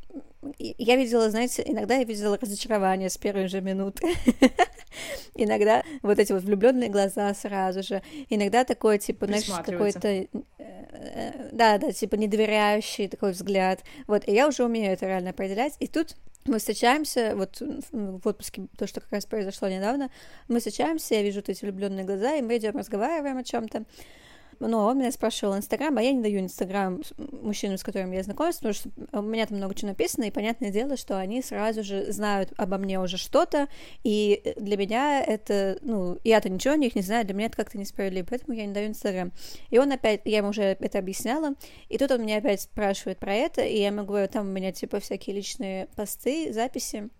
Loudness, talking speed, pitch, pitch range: -27 LUFS, 190 wpm, 215 Hz, 200-245 Hz